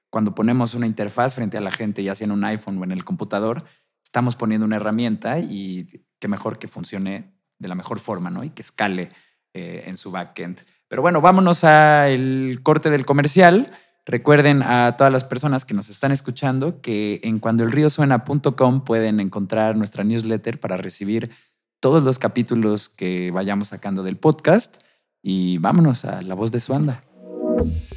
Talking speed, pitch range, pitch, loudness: 170 wpm, 100-135 Hz, 115 Hz, -19 LUFS